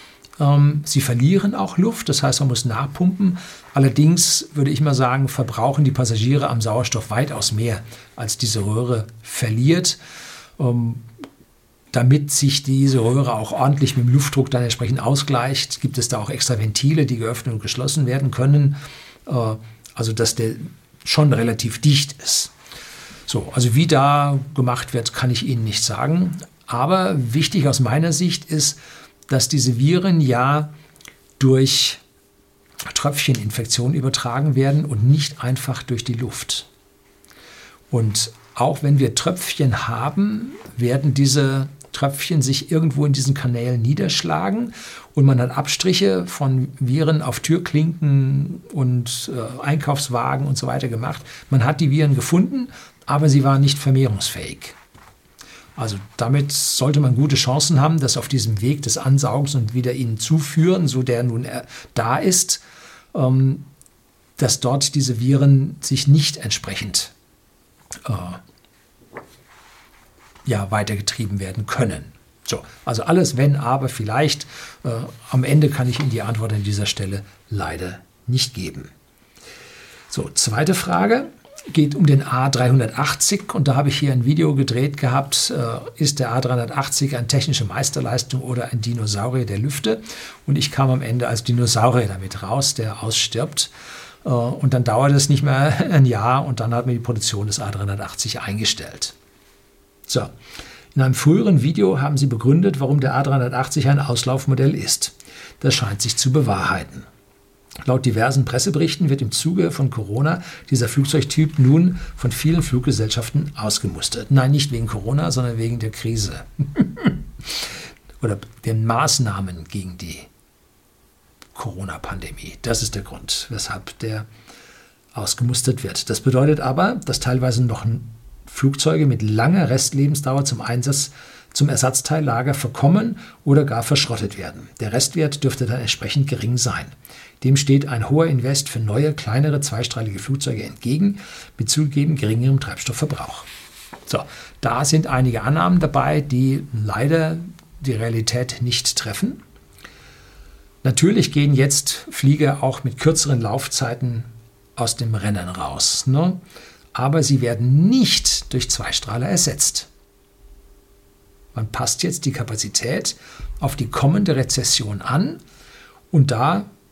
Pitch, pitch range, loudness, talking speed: 130 Hz, 115-145 Hz, -19 LUFS, 135 wpm